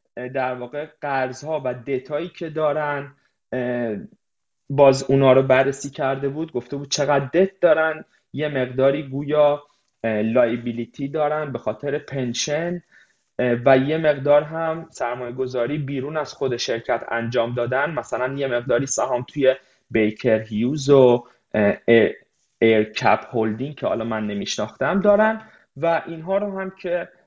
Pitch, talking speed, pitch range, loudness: 135 Hz, 130 wpm, 125-150 Hz, -21 LUFS